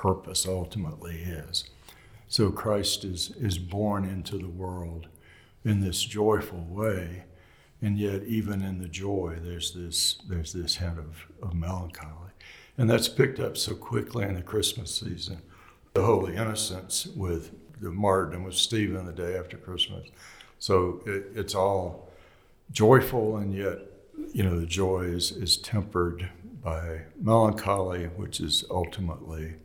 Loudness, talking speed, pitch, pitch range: -28 LUFS, 140 wpm, 95 Hz, 85-105 Hz